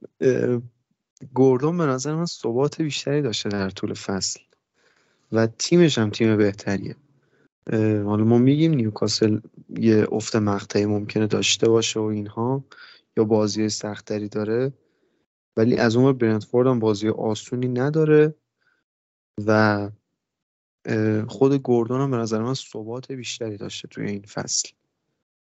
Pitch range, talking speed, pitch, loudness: 105-130 Hz, 120 wpm, 115 Hz, -22 LUFS